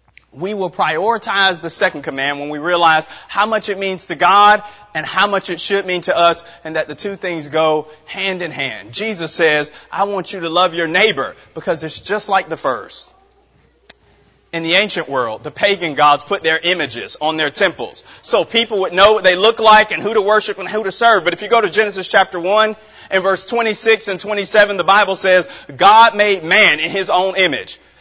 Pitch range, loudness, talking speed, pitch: 165-210 Hz, -15 LUFS, 210 wpm, 190 Hz